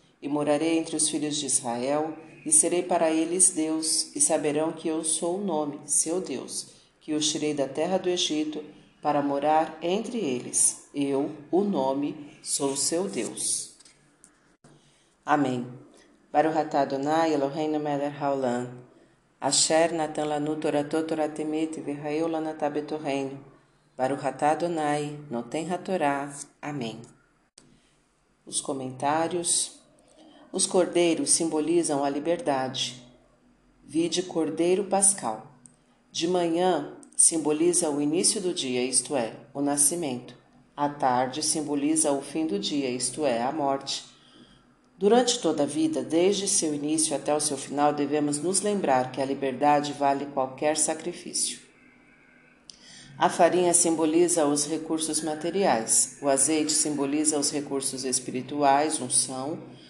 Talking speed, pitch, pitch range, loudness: 125 wpm, 150 Hz, 140-165 Hz, -25 LUFS